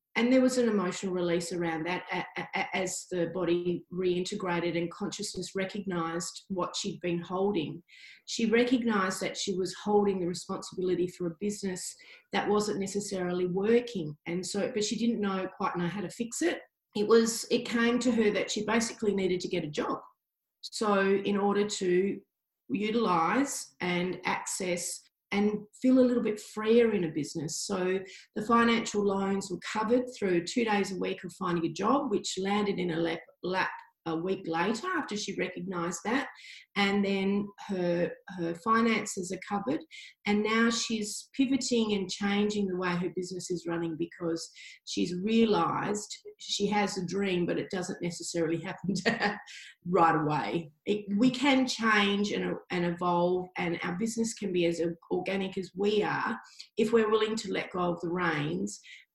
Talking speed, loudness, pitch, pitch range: 165 wpm, -30 LUFS, 195 Hz, 180-220 Hz